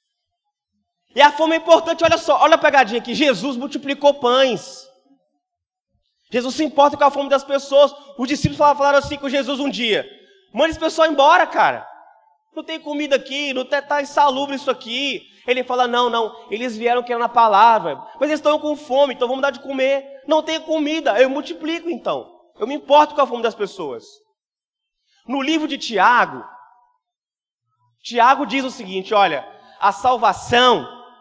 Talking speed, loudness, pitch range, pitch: 170 wpm, -18 LUFS, 250-305 Hz, 280 Hz